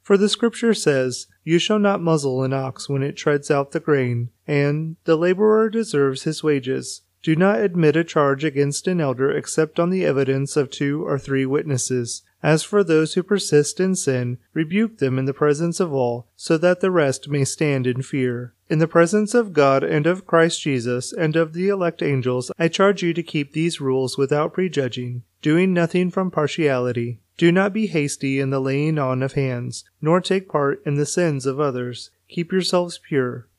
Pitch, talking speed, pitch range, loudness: 150 Hz, 195 wpm, 135-175 Hz, -20 LUFS